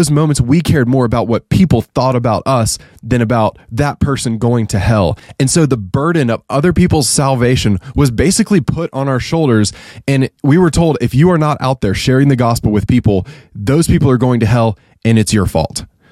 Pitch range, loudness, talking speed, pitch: 115-145 Hz, -13 LUFS, 210 wpm, 130 Hz